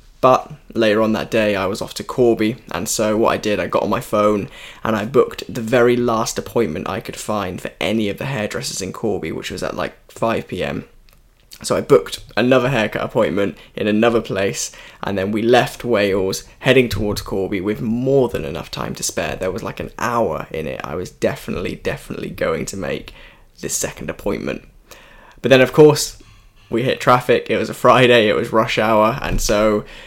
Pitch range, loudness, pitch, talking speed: 105-125 Hz, -18 LUFS, 110 Hz, 200 wpm